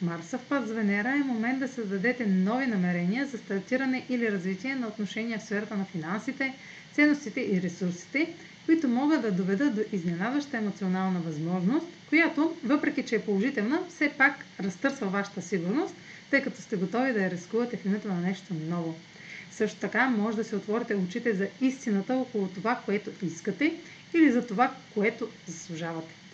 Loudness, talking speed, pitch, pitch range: -29 LUFS, 160 wpm, 220 Hz, 190-260 Hz